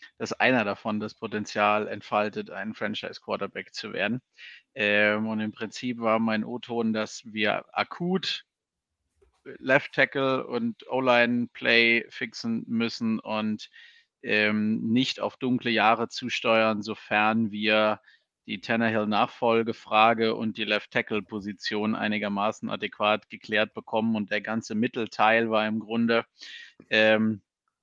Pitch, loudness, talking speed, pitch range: 110 Hz, -26 LUFS, 125 wpm, 105-115 Hz